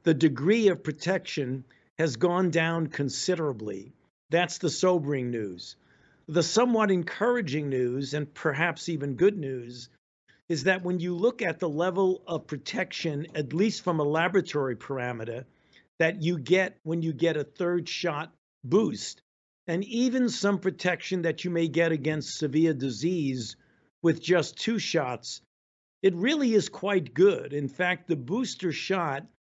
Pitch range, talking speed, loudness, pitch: 145-185 Hz, 145 wpm, -27 LUFS, 165 Hz